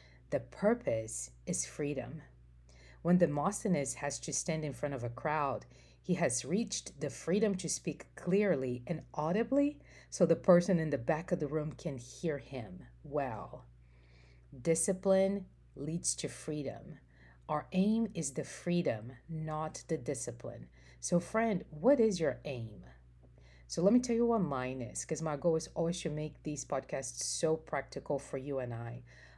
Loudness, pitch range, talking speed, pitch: -34 LUFS, 120-175 Hz, 160 wpm, 150 Hz